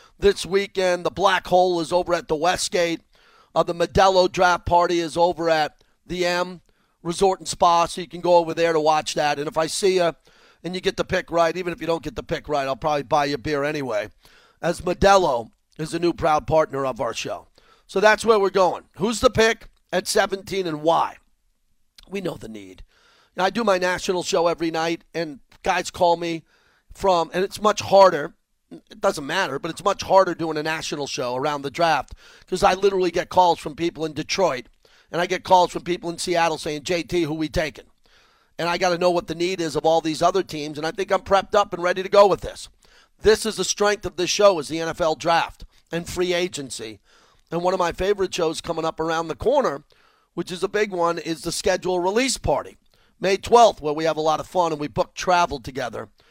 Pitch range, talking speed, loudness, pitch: 160-185 Hz, 225 wpm, -22 LUFS, 175 Hz